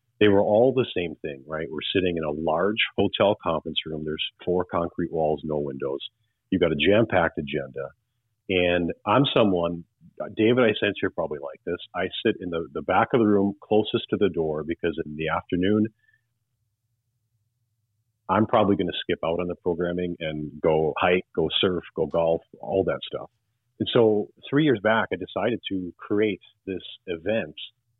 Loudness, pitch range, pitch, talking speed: -25 LUFS, 80-110 Hz, 90 Hz, 180 wpm